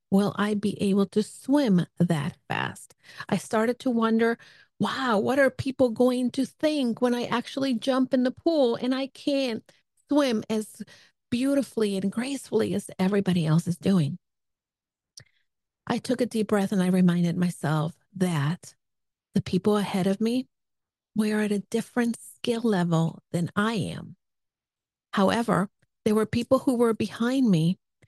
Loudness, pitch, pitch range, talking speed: -26 LUFS, 215 Hz, 180-245 Hz, 150 wpm